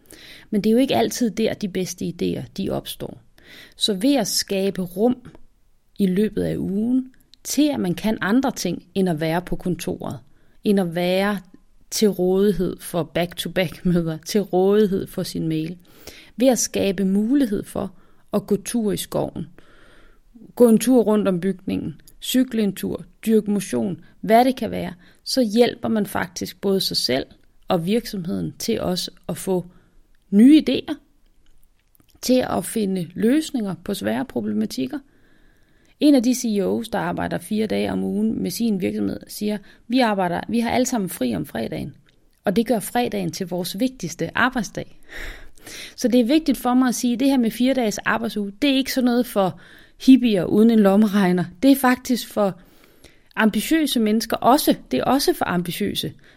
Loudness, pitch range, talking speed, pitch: -21 LUFS, 190-245 Hz, 170 wpm, 215 Hz